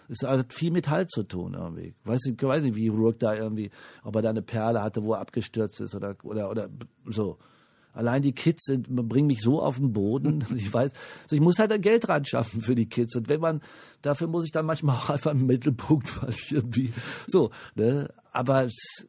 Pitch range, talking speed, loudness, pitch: 115-150 Hz, 220 wpm, -27 LUFS, 130 Hz